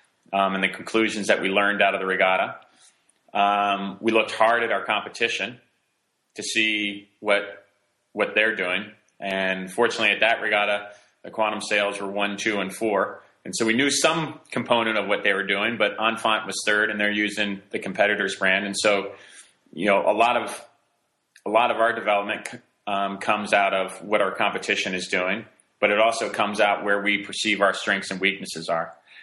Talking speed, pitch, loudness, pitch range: 190 wpm, 100 Hz, -23 LUFS, 100-105 Hz